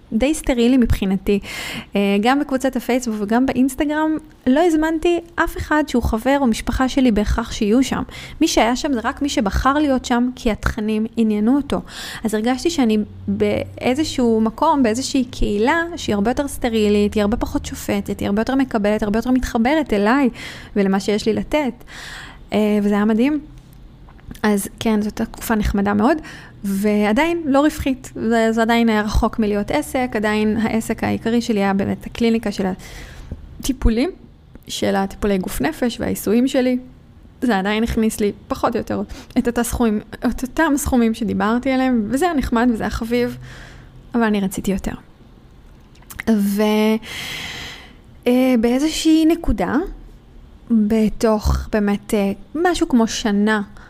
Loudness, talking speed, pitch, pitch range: -19 LUFS, 135 wpm, 230 Hz, 215-265 Hz